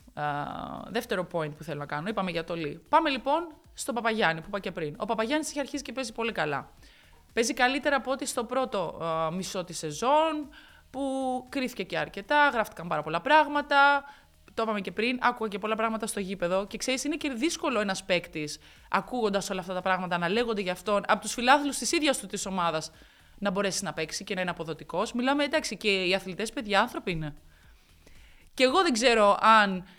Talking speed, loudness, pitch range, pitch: 205 wpm, -28 LUFS, 175-265 Hz, 215 Hz